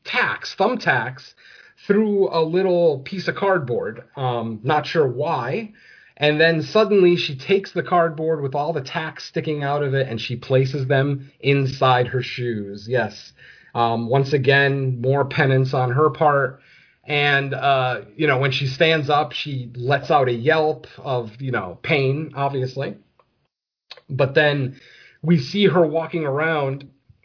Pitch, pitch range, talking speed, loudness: 140 Hz, 130-160 Hz, 150 wpm, -20 LUFS